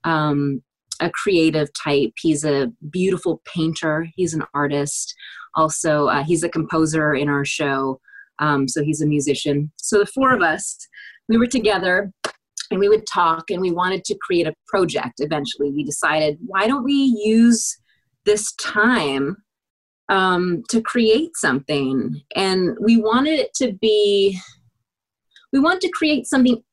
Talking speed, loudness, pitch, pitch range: 150 wpm, -19 LUFS, 175 Hz, 150-225 Hz